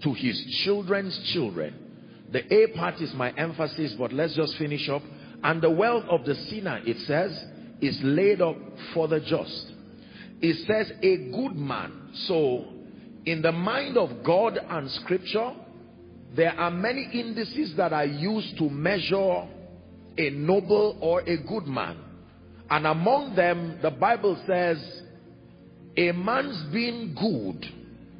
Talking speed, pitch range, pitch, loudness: 145 wpm, 150-205 Hz, 170 Hz, -26 LUFS